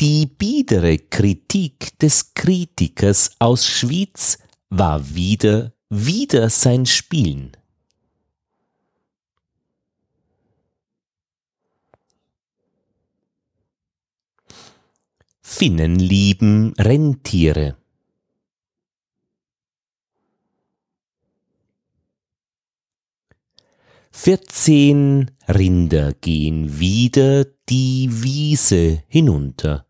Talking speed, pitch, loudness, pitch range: 45 wpm, 115 Hz, -16 LUFS, 90-145 Hz